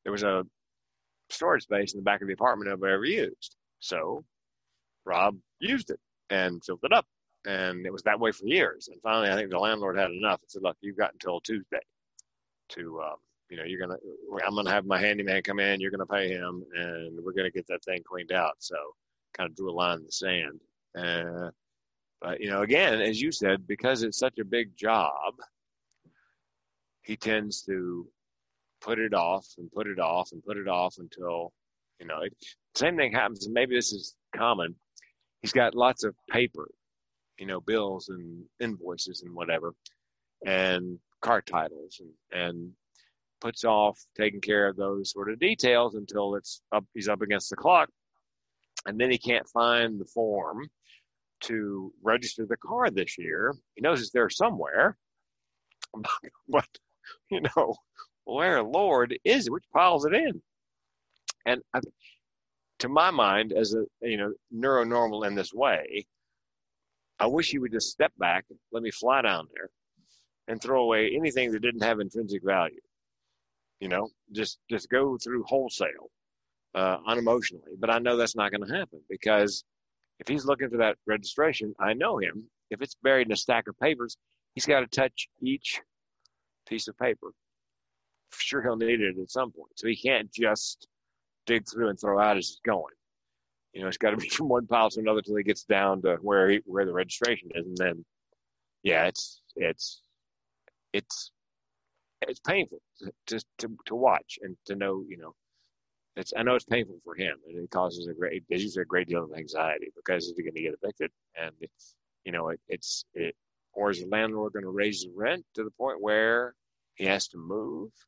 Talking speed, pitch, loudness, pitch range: 185 wpm, 100 Hz, -28 LUFS, 85-115 Hz